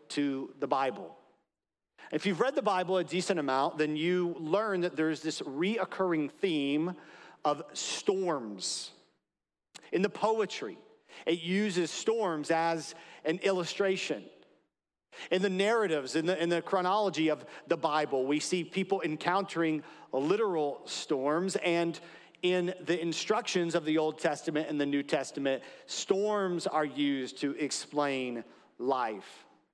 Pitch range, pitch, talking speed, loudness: 155-190 Hz, 170 Hz, 130 wpm, -31 LUFS